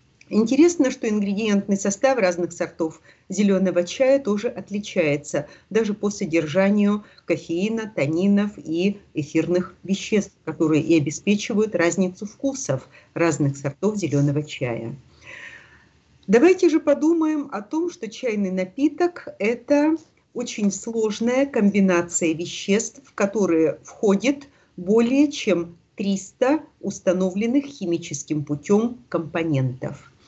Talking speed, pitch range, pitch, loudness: 100 wpm, 170-235 Hz, 200 Hz, -22 LUFS